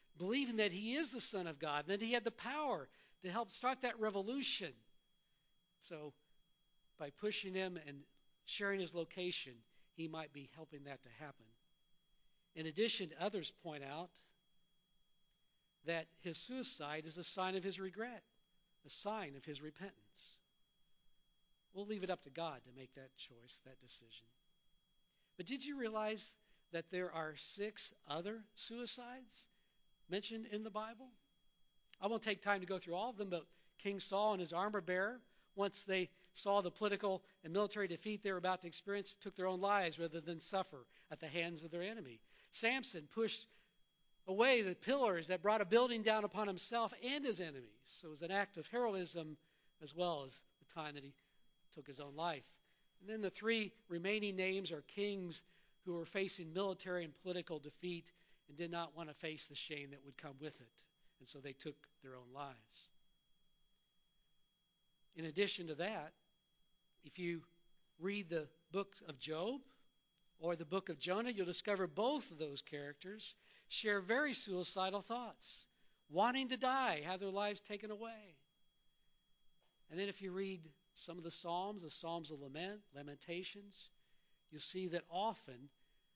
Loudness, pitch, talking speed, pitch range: -42 LUFS, 180 Hz, 170 wpm, 160-205 Hz